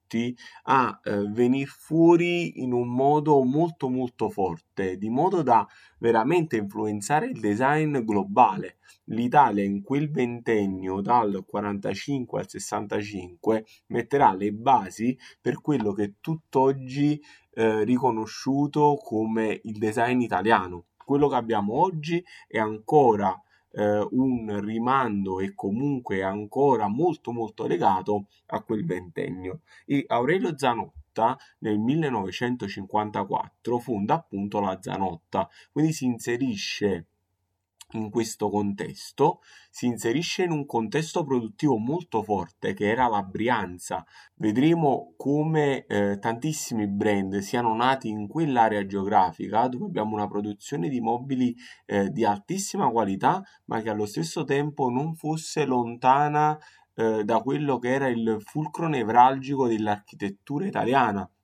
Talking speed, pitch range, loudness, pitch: 120 wpm, 105-140 Hz, -25 LUFS, 115 Hz